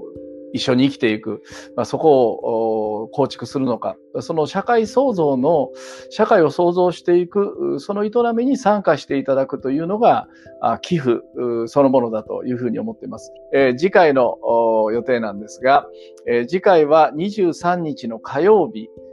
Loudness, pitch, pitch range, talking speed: -18 LUFS, 135 Hz, 115-180 Hz, 295 characters per minute